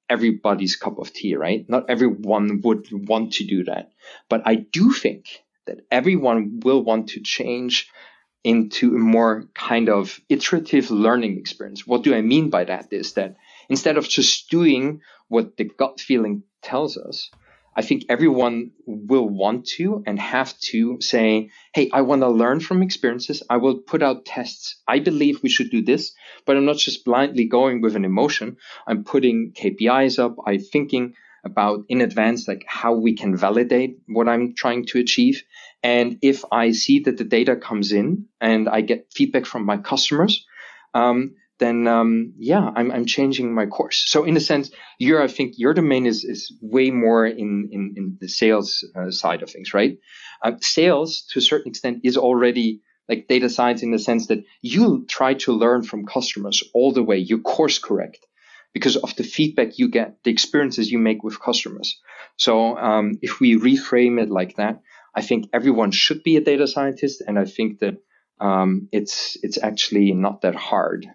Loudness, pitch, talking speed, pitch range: -20 LUFS, 120 Hz, 185 wpm, 110-135 Hz